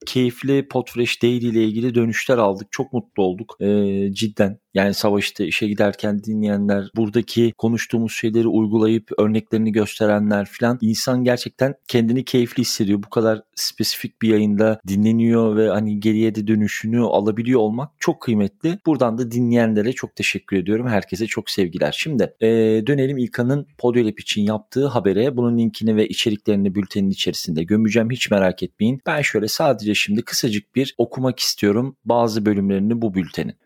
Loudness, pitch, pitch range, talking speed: -20 LUFS, 110 Hz, 105-120 Hz, 150 wpm